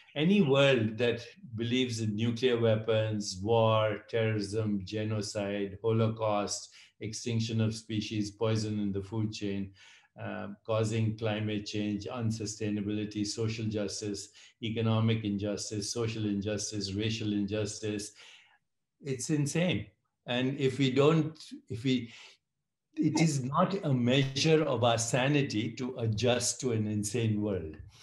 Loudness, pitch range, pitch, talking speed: -31 LUFS, 105-125 Hz, 110 Hz, 115 wpm